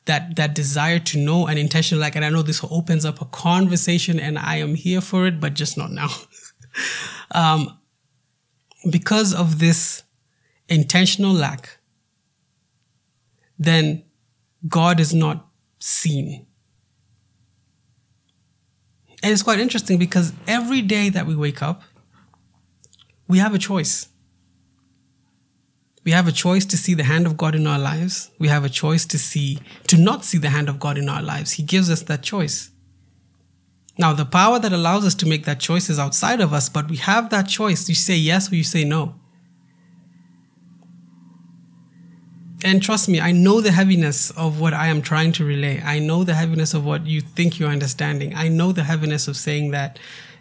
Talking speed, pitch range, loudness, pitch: 170 wpm, 145-175 Hz, -19 LUFS, 160 Hz